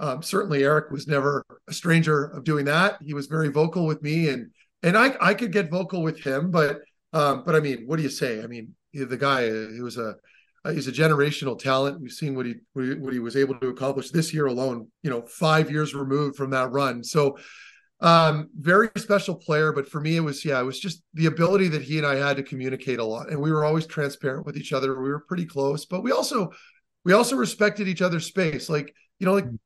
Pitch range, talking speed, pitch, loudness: 135-165 Hz, 240 wpm, 150 Hz, -24 LUFS